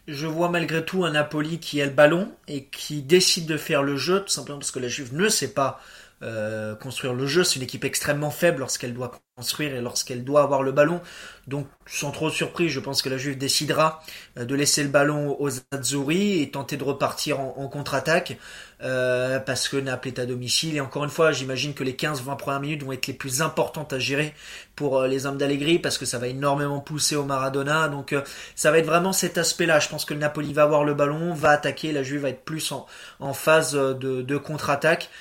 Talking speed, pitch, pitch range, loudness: 230 wpm, 145 Hz, 135-155 Hz, -24 LUFS